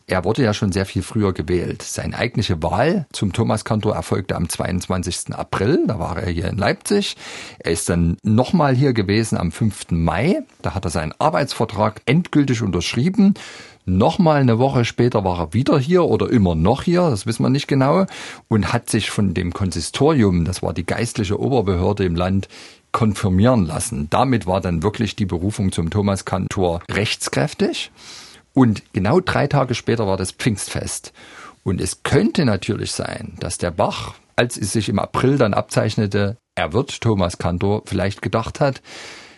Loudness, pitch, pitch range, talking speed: -19 LUFS, 105 Hz, 95-125 Hz, 170 wpm